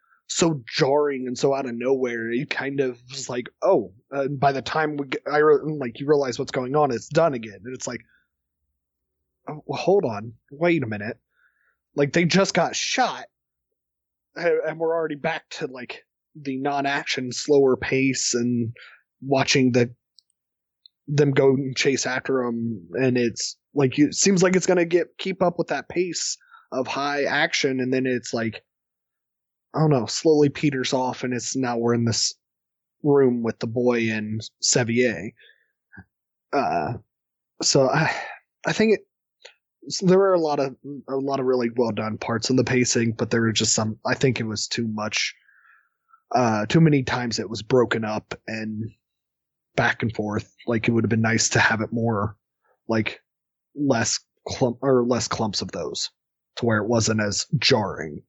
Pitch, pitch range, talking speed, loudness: 130 Hz, 115-145 Hz, 180 wpm, -23 LUFS